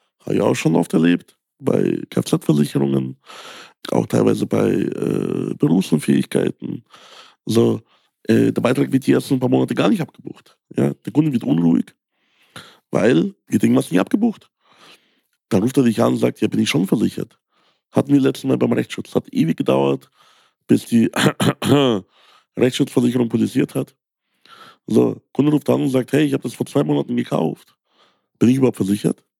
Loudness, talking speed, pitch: -19 LUFS, 175 wpm, 115 Hz